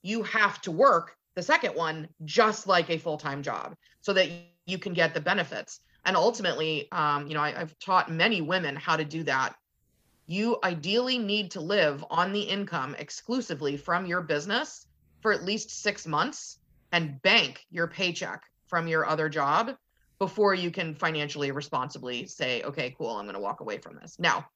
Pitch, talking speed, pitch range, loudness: 175 Hz, 185 wpm, 155-200 Hz, -28 LUFS